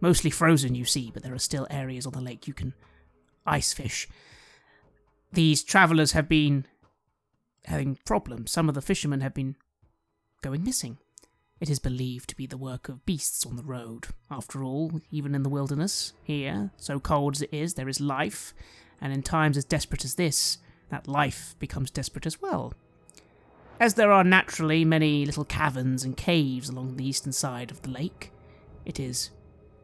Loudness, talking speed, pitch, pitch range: -27 LUFS, 175 wpm, 140 Hz, 130-155 Hz